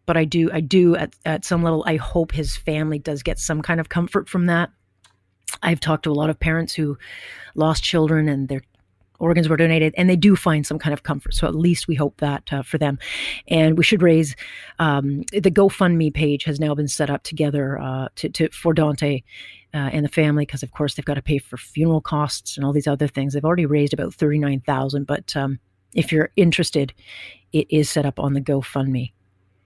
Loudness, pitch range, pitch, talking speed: -20 LUFS, 140-160 Hz, 150 Hz, 225 wpm